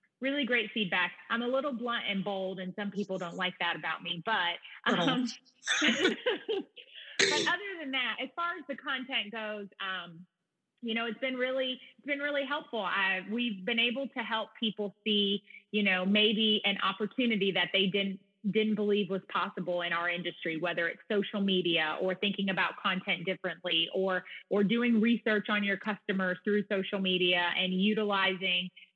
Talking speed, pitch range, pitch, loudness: 170 wpm, 185-235 Hz, 205 Hz, -31 LUFS